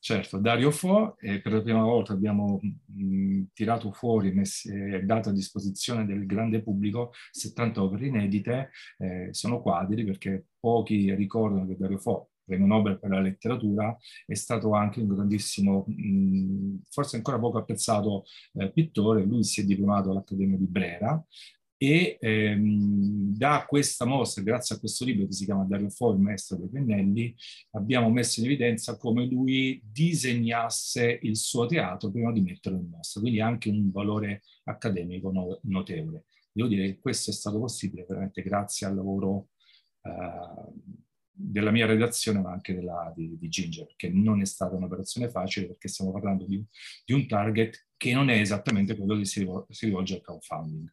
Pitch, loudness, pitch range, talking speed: 105 Hz, -28 LUFS, 95-115 Hz, 165 wpm